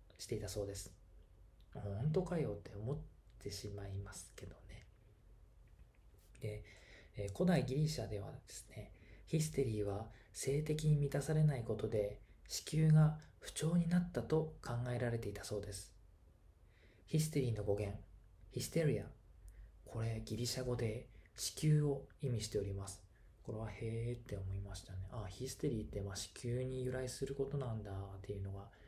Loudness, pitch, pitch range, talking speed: -40 LUFS, 110 Hz, 100-130 Hz, 315 characters per minute